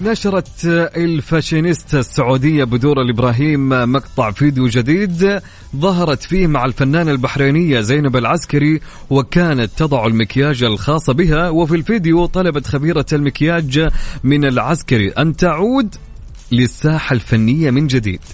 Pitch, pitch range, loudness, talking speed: 145 Hz, 130-170 Hz, -15 LUFS, 110 wpm